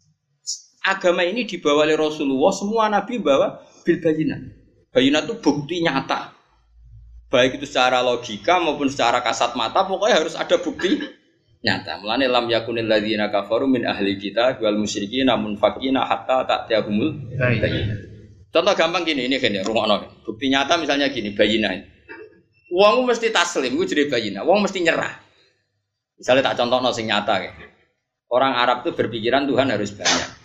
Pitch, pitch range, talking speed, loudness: 130 Hz, 105-155 Hz, 150 wpm, -20 LUFS